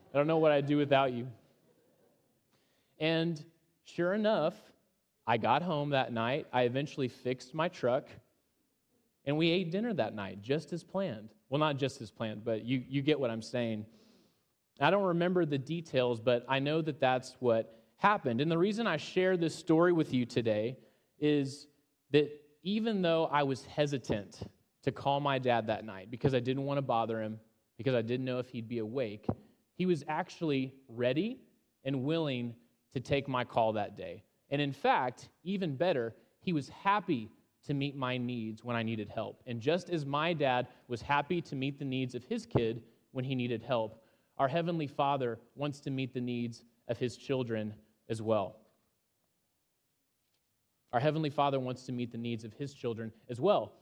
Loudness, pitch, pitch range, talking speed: -33 LUFS, 135 Hz, 120-155 Hz, 185 wpm